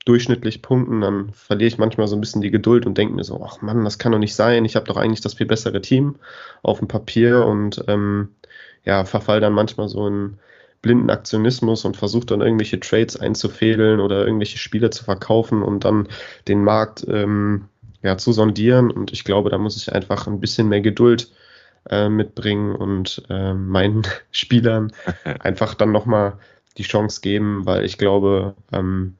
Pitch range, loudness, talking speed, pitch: 100-115 Hz, -19 LUFS, 185 wpm, 105 Hz